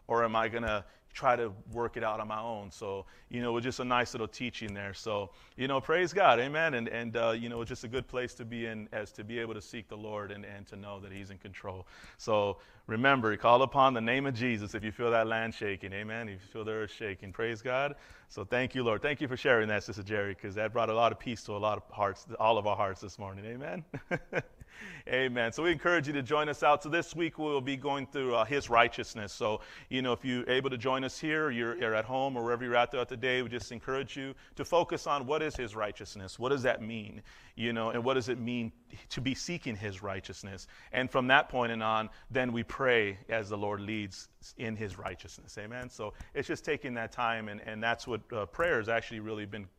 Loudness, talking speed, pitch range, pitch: -32 LUFS, 255 wpm, 105-130 Hz, 115 Hz